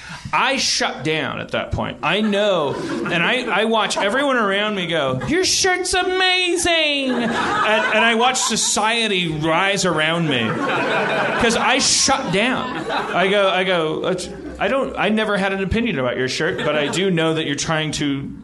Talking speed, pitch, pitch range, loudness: 170 wpm, 195 Hz, 160-240 Hz, -18 LUFS